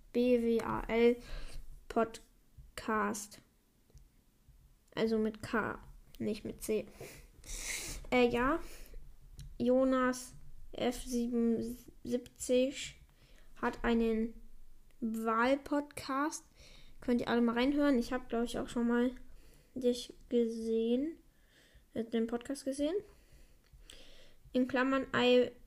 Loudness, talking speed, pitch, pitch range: -34 LUFS, 85 wpm, 245 Hz, 230-255 Hz